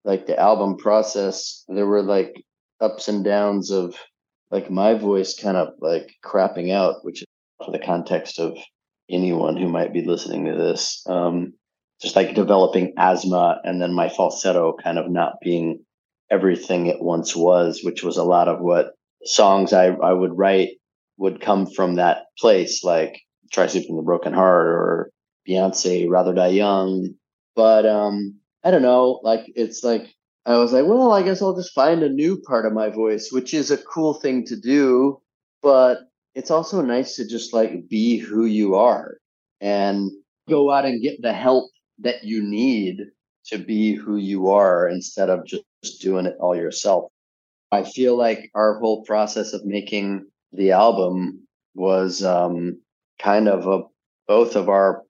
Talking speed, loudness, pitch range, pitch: 170 wpm, -20 LUFS, 95-115 Hz, 100 Hz